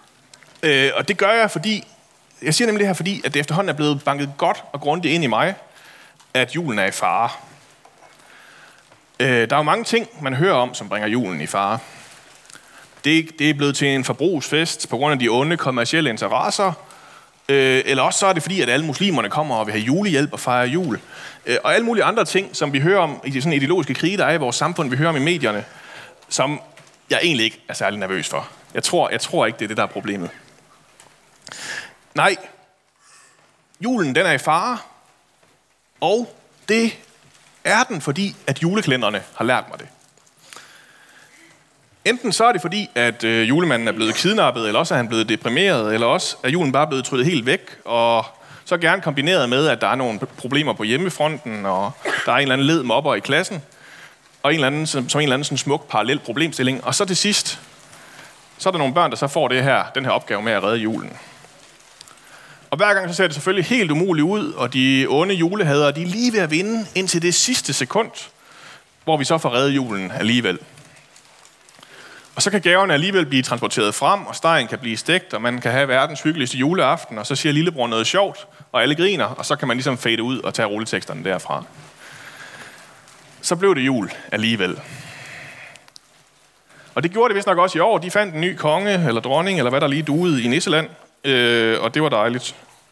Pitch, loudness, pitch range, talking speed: 150 Hz, -19 LUFS, 130-185 Hz, 205 wpm